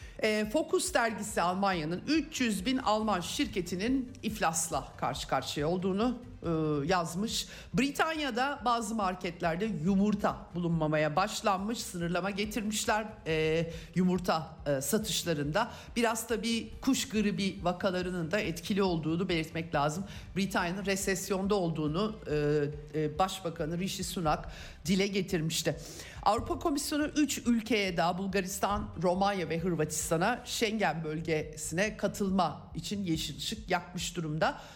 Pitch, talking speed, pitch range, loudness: 190 Hz, 100 wpm, 165-215 Hz, -32 LUFS